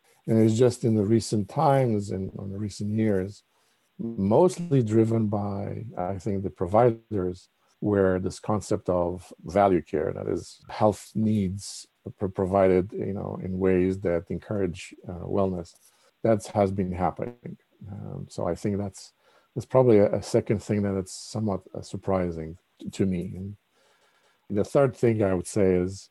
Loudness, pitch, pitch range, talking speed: -26 LUFS, 100 Hz, 95-110 Hz, 155 wpm